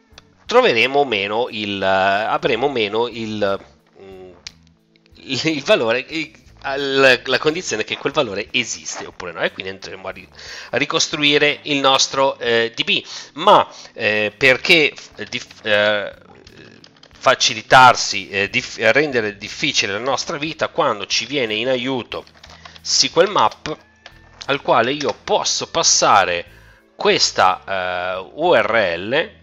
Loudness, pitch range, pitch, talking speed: -17 LUFS, 100-135 Hz, 120 Hz, 120 wpm